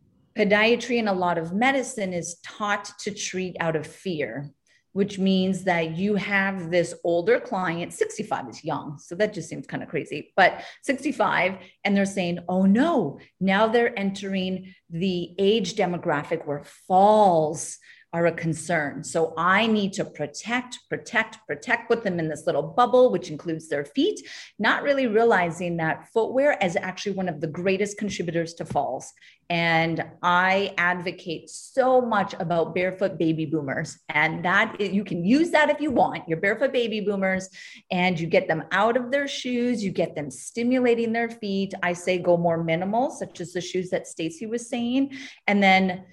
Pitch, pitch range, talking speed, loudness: 190 Hz, 170-220 Hz, 170 wpm, -24 LUFS